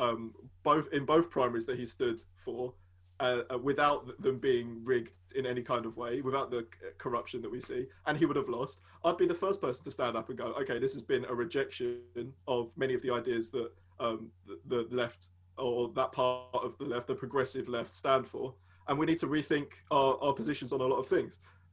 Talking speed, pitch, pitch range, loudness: 220 wpm, 125 Hz, 115-135 Hz, -34 LUFS